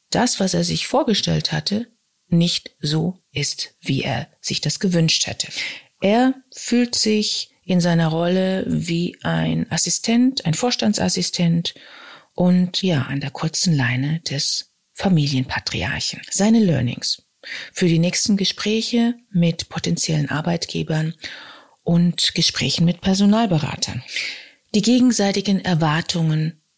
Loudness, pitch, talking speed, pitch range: -19 LUFS, 175 Hz, 110 wpm, 160-205 Hz